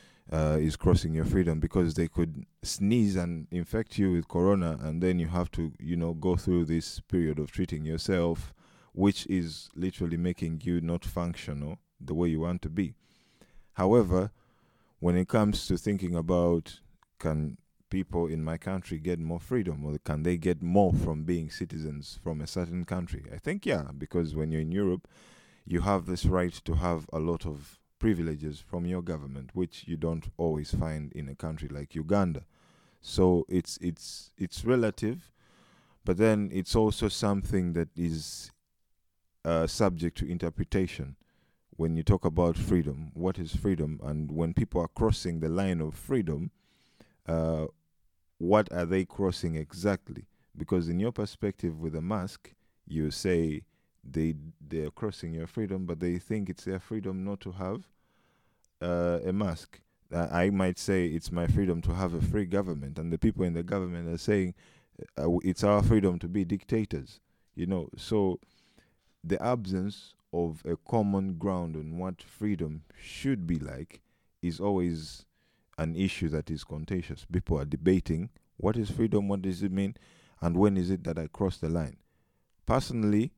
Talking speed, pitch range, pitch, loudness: 170 wpm, 80-95 Hz, 85 Hz, -31 LUFS